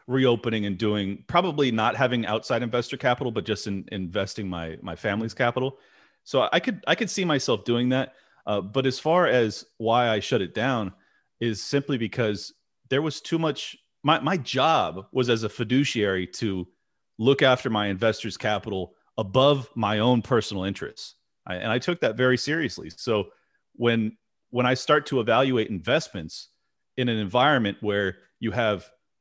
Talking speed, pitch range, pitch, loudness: 170 wpm, 105-130 Hz, 115 Hz, -25 LUFS